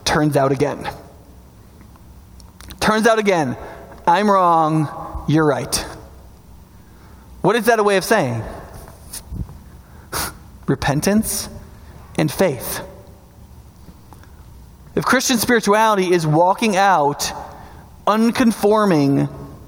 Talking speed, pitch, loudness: 80 wpm, 155 Hz, -17 LUFS